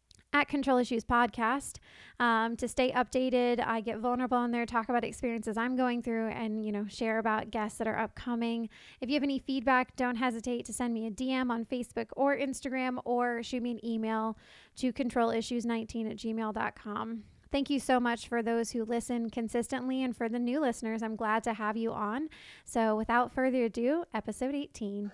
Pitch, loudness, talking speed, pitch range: 235 Hz, -32 LUFS, 190 wpm, 225-255 Hz